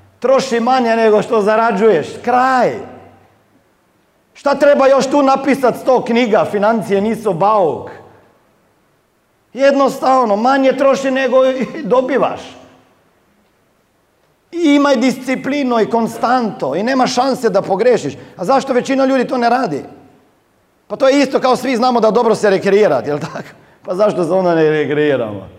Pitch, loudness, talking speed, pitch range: 245 Hz, -14 LUFS, 135 wpm, 210-265 Hz